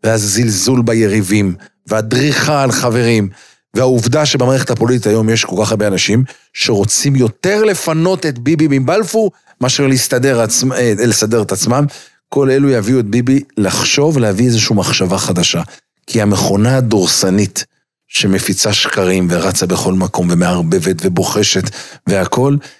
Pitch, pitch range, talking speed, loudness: 120 Hz, 105-135 Hz, 120 wpm, -13 LUFS